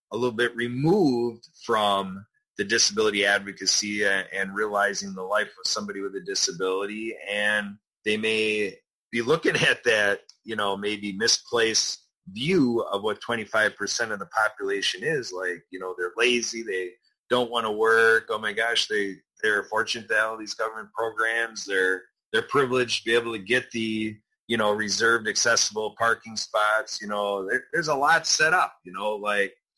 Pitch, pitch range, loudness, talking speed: 110 Hz, 100-115 Hz, -24 LUFS, 165 wpm